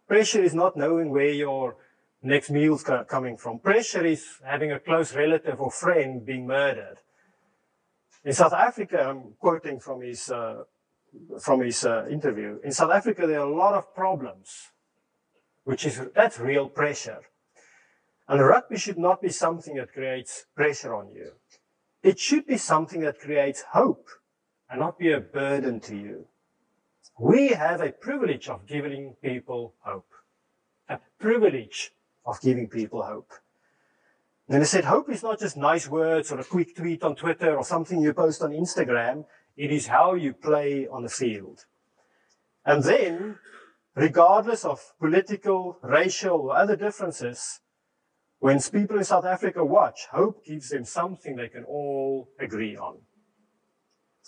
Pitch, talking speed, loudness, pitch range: 150 Hz, 155 wpm, -25 LUFS, 135-175 Hz